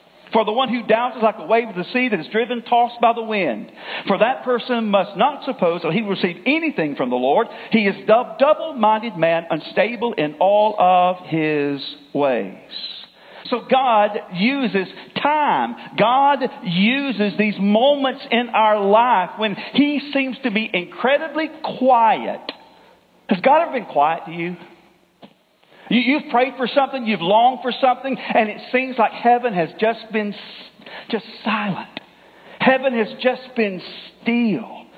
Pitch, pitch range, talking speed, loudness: 225 Hz, 200-255 Hz, 160 wpm, -19 LUFS